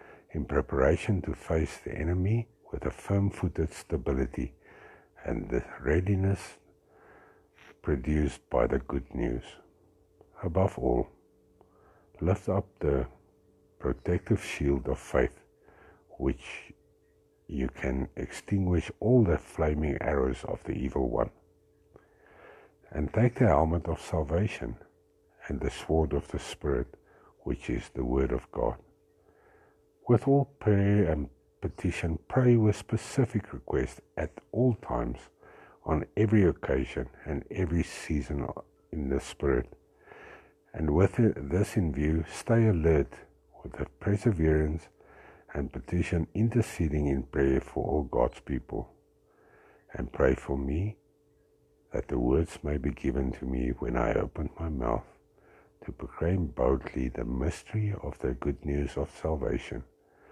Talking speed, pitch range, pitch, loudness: 125 wpm, 75-100 Hz, 85 Hz, -30 LUFS